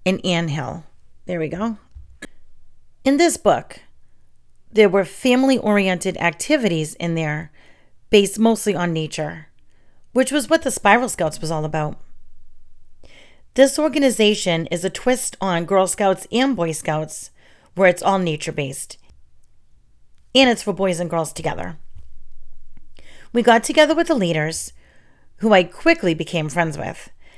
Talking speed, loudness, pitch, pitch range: 135 wpm, -19 LUFS, 185 Hz, 160-225 Hz